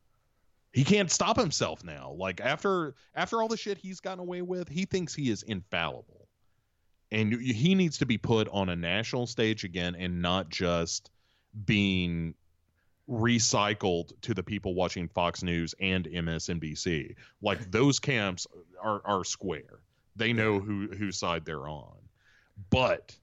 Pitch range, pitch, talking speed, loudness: 90-130 Hz, 105 Hz, 150 wpm, -30 LUFS